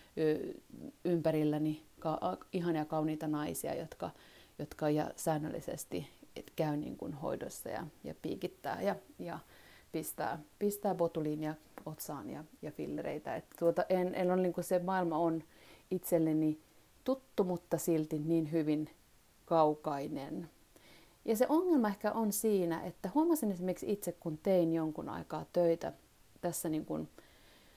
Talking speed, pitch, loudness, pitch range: 125 wpm, 170 Hz, -36 LUFS, 155-190 Hz